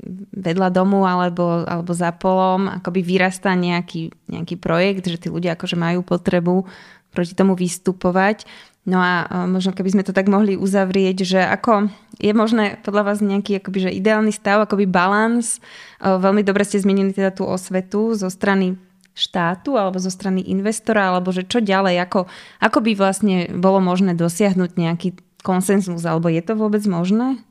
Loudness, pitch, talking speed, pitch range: -19 LUFS, 190 Hz, 160 wpm, 180-205 Hz